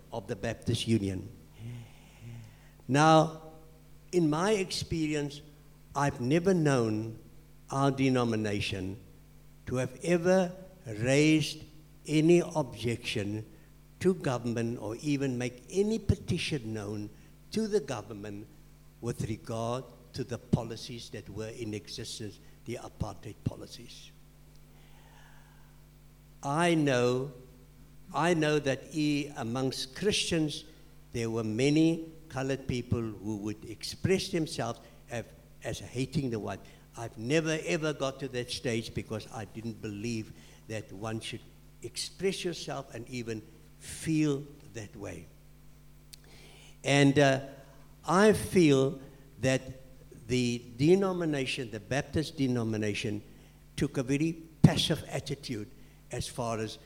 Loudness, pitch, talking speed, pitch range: -31 LUFS, 135 Hz, 110 wpm, 115-155 Hz